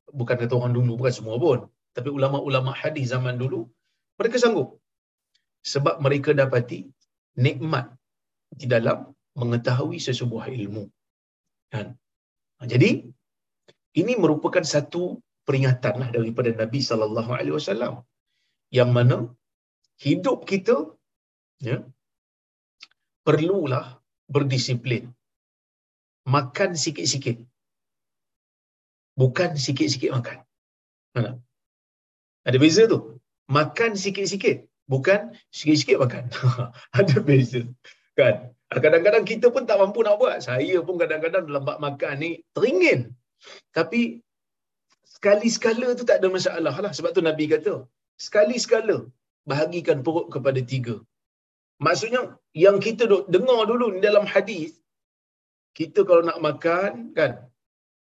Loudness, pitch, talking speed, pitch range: -23 LUFS, 140 Hz, 105 wpm, 120-175 Hz